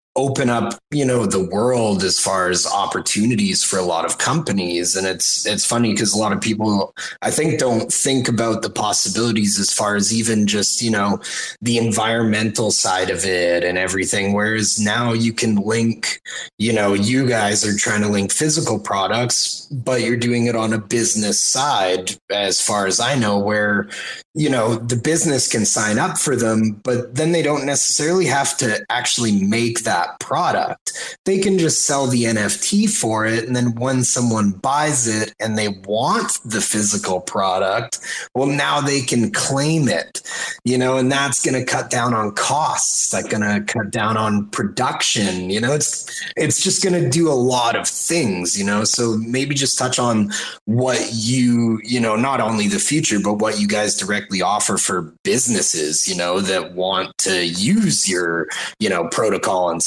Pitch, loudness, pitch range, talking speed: 115 Hz, -18 LUFS, 105-130 Hz, 185 wpm